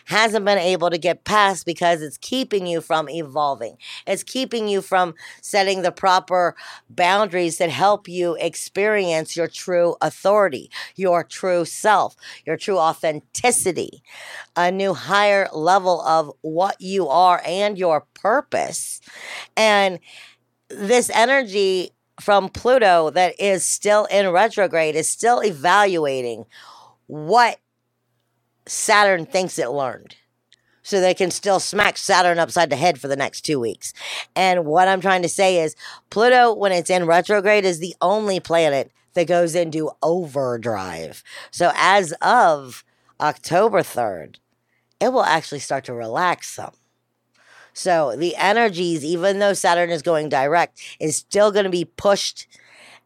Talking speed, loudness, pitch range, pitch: 140 wpm, -19 LUFS, 160-200 Hz, 180 Hz